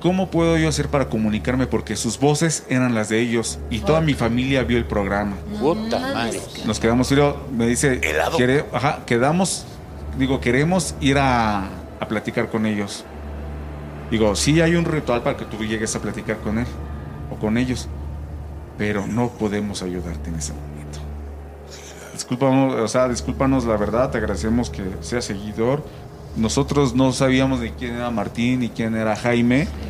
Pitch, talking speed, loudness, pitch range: 115 Hz, 160 wpm, -21 LUFS, 95-130 Hz